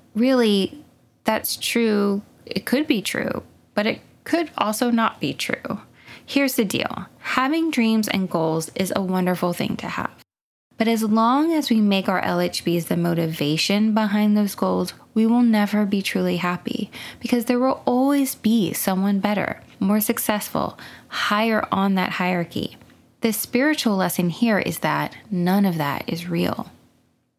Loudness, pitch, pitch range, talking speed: -22 LUFS, 210 Hz, 185-240 Hz, 155 wpm